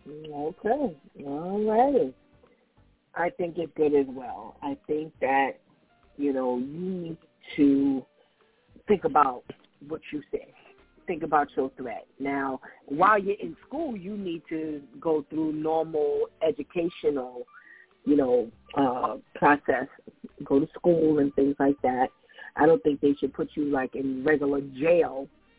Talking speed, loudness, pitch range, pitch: 140 wpm, -27 LUFS, 140-175 Hz, 155 Hz